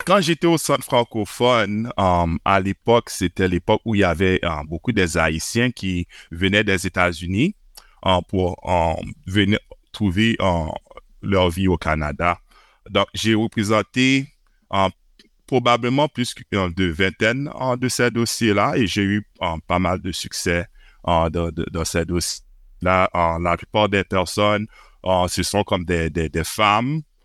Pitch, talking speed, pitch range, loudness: 95 Hz, 165 wpm, 85-110 Hz, -20 LUFS